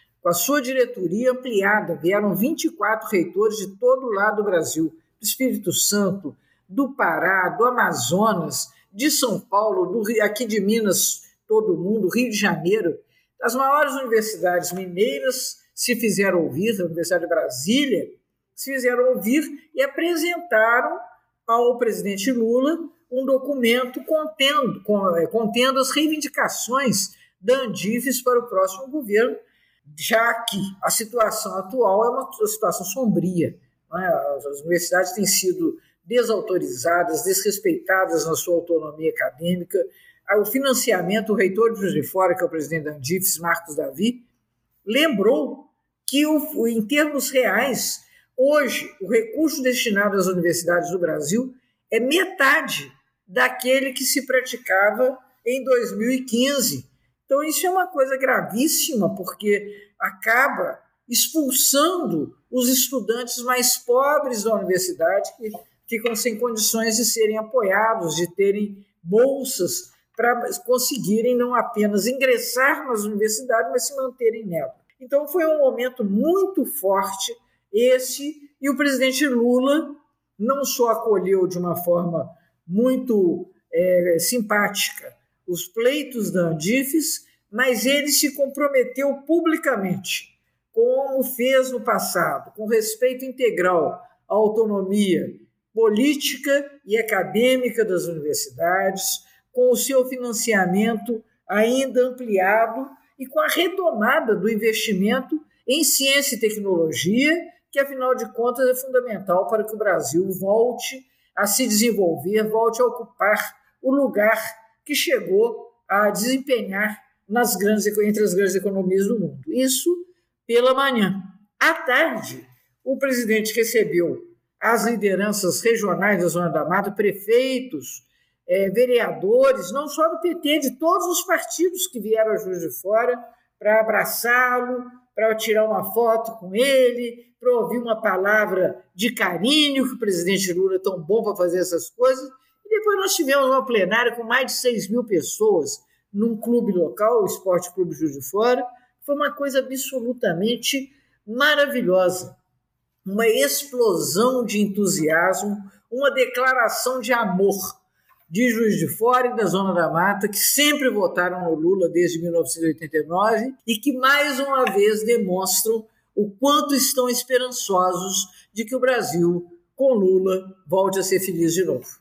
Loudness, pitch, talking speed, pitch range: -21 LUFS, 230 Hz, 130 wpm, 195-265 Hz